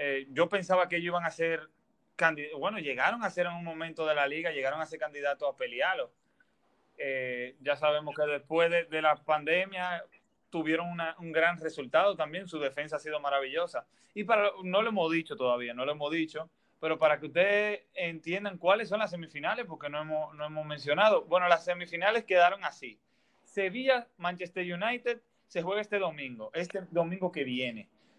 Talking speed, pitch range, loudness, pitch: 185 wpm, 150-185 Hz, -31 LUFS, 165 Hz